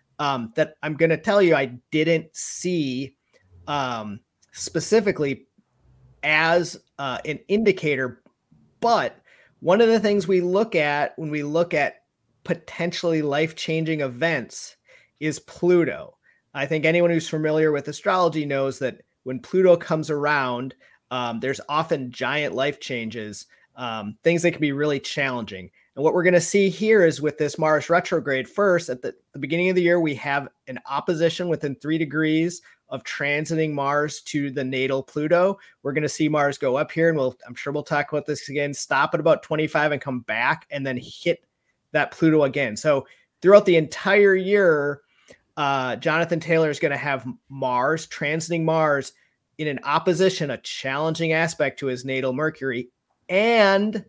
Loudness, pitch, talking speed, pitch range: -22 LUFS, 155 Hz, 165 wpm, 135-170 Hz